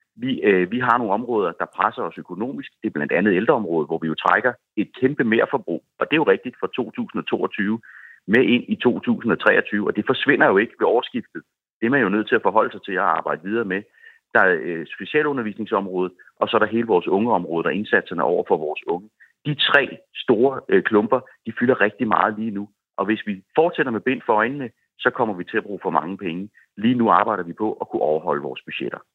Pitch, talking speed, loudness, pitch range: 110 Hz, 230 wpm, -21 LUFS, 100-150 Hz